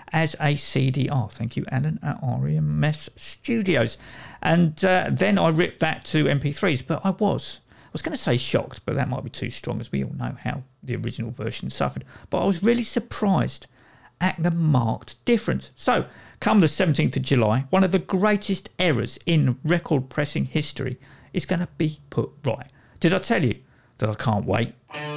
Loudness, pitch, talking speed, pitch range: -24 LUFS, 150 Hz, 190 wpm, 130-185 Hz